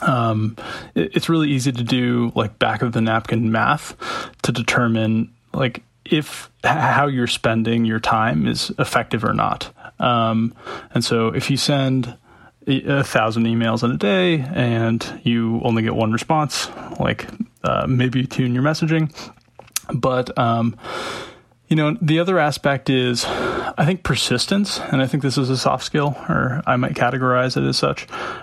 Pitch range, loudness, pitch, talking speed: 115-145 Hz, -20 LUFS, 125 Hz, 165 wpm